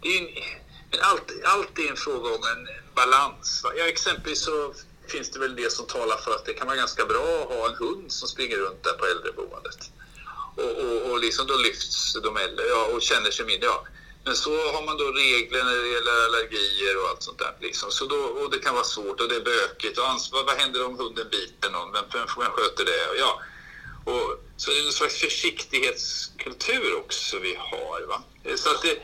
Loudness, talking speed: -25 LUFS, 215 wpm